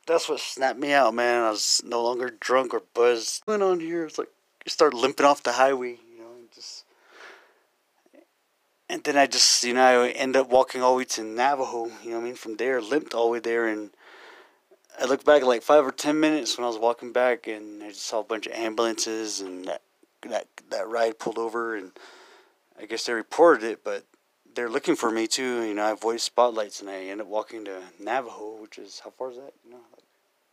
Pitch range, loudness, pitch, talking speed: 110-130 Hz, -24 LUFS, 120 Hz, 230 wpm